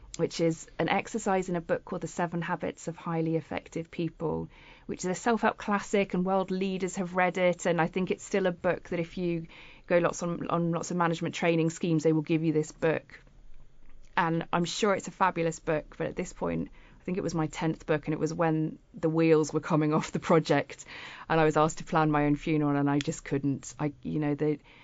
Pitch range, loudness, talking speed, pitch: 155-180 Hz, -29 LUFS, 235 wpm, 165 Hz